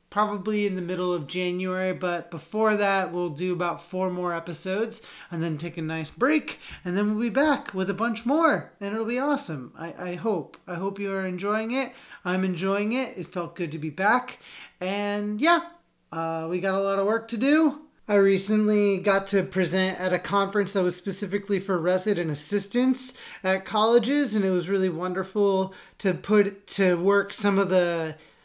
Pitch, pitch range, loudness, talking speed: 195 Hz, 180-210 Hz, -25 LUFS, 190 wpm